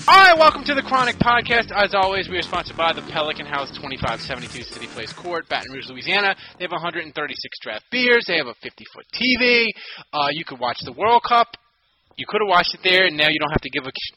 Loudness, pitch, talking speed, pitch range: -19 LUFS, 180 Hz, 230 wpm, 150-235 Hz